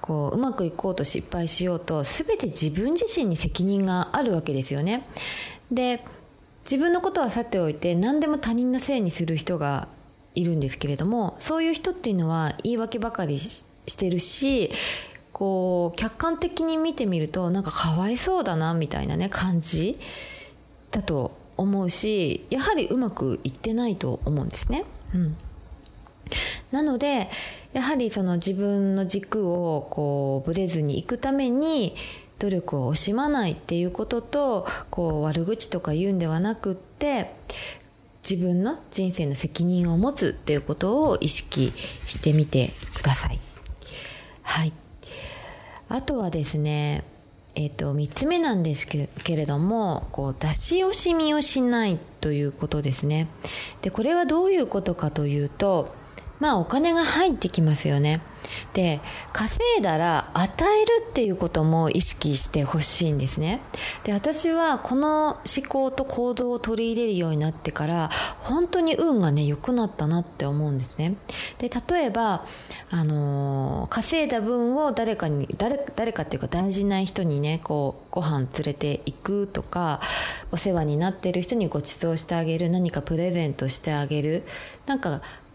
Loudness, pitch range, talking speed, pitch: -25 LUFS, 155-245 Hz, 305 characters per minute, 185 Hz